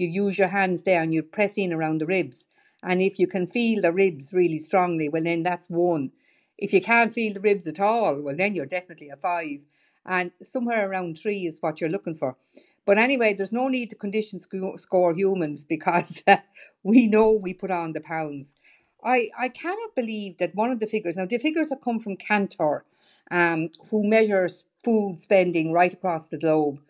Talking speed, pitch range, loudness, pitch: 200 wpm, 170-215 Hz, -24 LUFS, 185 Hz